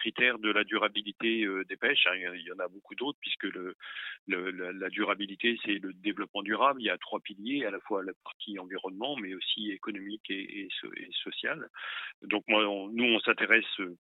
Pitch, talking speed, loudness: 110 Hz, 215 wpm, -31 LUFS